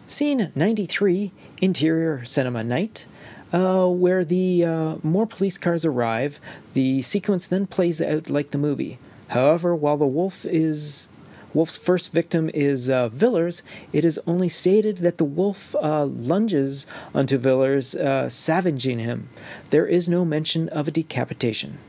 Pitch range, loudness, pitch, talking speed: 140-180 Hz, -22 LUFS, 160 Hz, 145 wpm